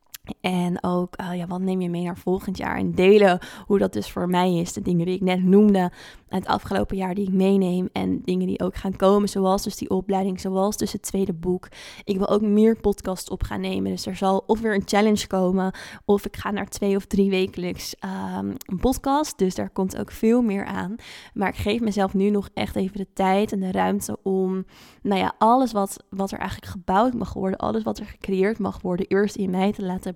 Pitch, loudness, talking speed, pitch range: 195 Hz, -23 LUFS, 230 wpm, 185-205 Hz